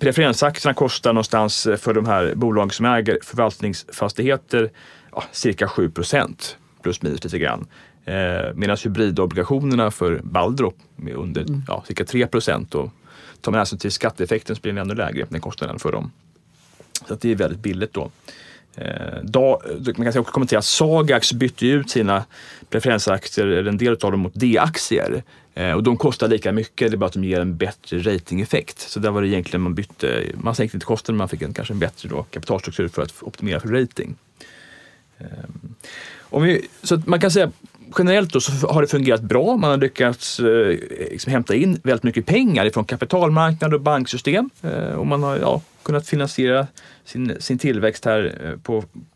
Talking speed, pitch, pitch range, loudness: 175 wpm, 120 Hz, 105-140 Hz, -20 LUFS